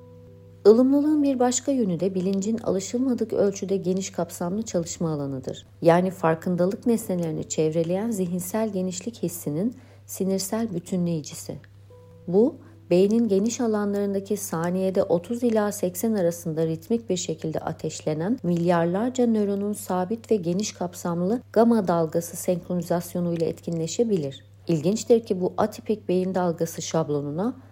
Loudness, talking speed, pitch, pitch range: -25 LUFS, 115 wpm, 185 Hz, 170-220 Hz